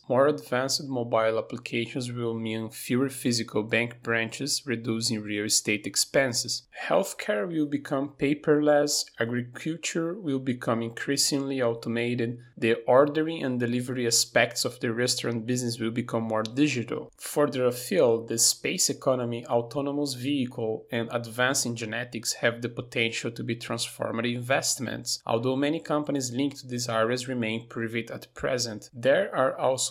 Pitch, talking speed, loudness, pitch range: 120 Hz, 135 wpm, -27 LUFS, 115-140 Hz